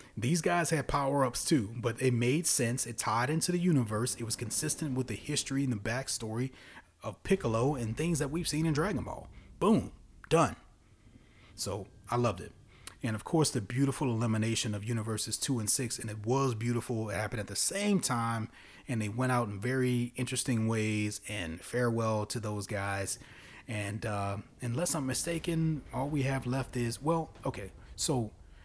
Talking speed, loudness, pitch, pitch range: 180 wpm, -32 LUFS, 120 Hz, 110-135 Hz